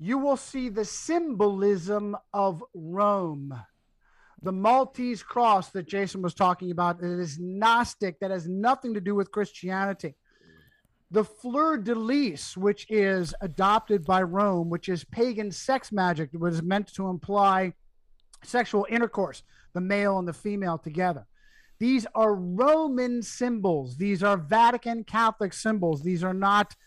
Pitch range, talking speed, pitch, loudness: 180-230 Hz, 140 wpm, 200 Hz, -26 LUFS